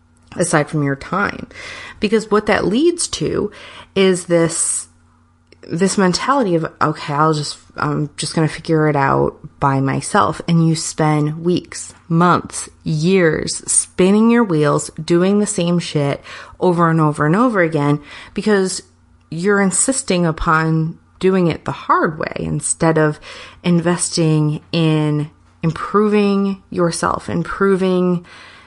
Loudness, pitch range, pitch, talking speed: -17 LUFS, 150-190 Hz, 165 Hz, 130 wpm